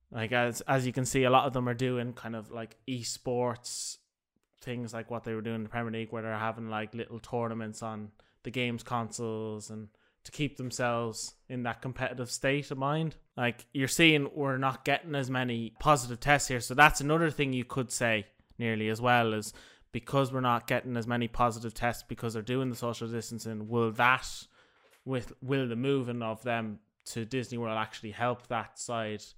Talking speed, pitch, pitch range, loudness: 200 wpm, 120 Hz, 115-130 Hz, -31 LUFS